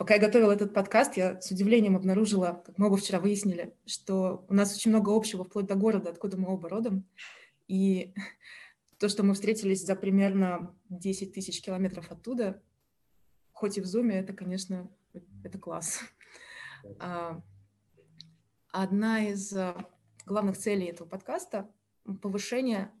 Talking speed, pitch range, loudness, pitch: 140 wpm, 185-210 Hz, -29 LUFS, 195 Hz